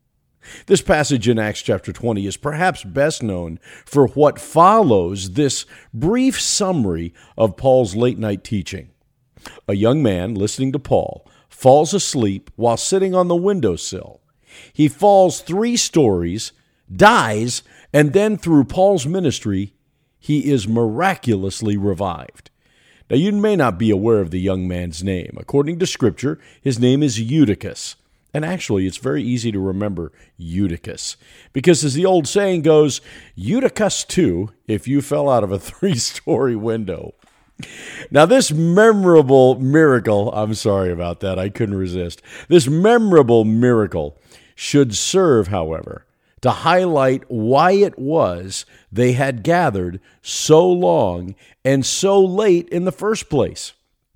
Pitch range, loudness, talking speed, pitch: 100-160 Hz, -17 LUFS, 135 wpm, 130 Hz